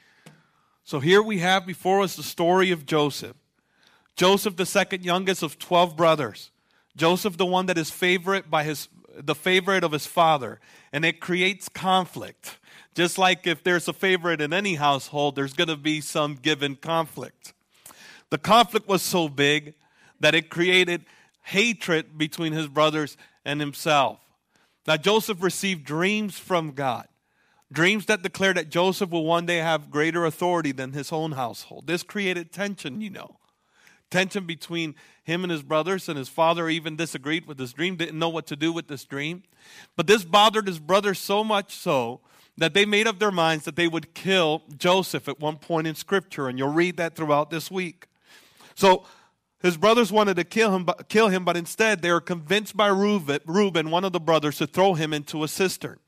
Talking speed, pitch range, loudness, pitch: 180 wpm, 155-190 Hz, -23 LUFS, 170 Hz